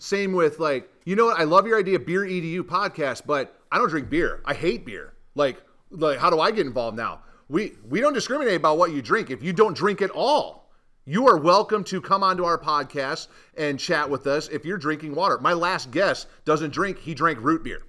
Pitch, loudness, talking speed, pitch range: 175 Hz, -23 LUFS, 230 wpm, 155-195 Hz